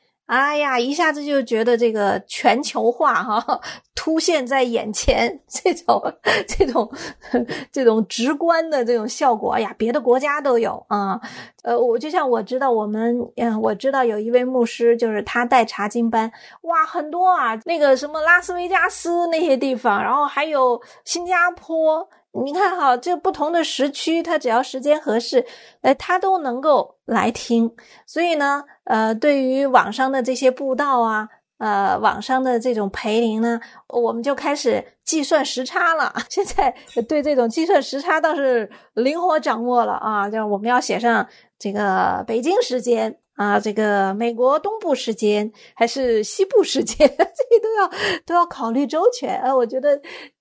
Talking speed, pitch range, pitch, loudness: 245 characters per minute, 235-320 Hz, 265 Hz, -19 LUFS